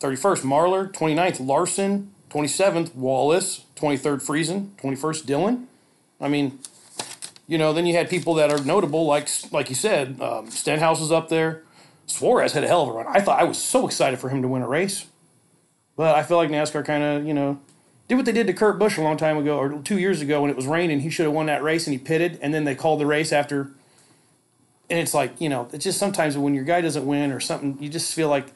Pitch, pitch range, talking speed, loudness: 155 Hz, 145-170 Hz, 235 wpm, -22 LUFS